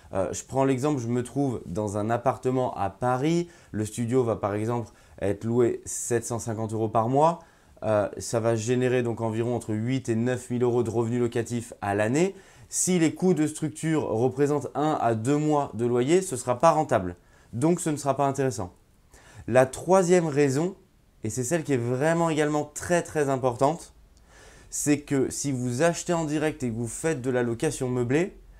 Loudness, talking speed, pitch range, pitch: -26 LUFS, 190 wpm, 115-150 Hz, 130 Hz